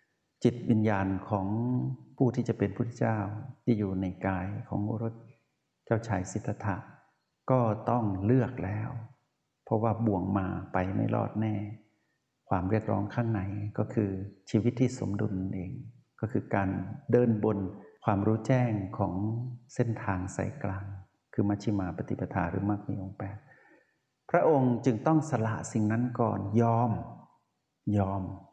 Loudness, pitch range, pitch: -30 LUFS, 100-120 Hz, 110 Hz